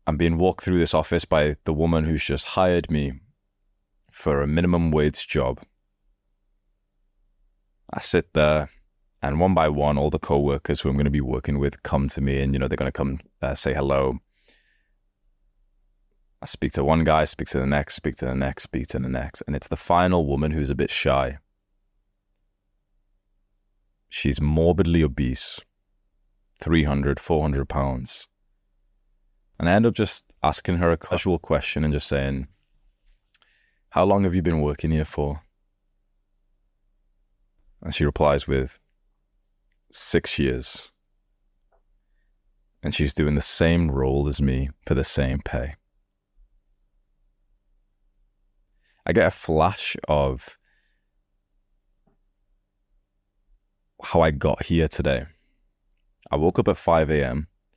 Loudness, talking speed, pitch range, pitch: -23 LUFS, 140 wpm, 75-100 Hz, 90 Hz